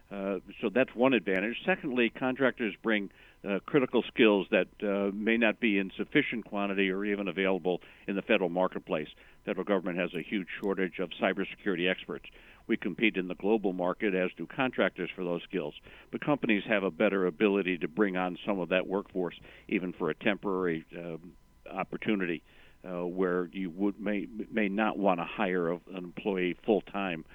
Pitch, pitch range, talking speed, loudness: 95 Hz, 90-105 Hz, 180 wpm, -31 LUFS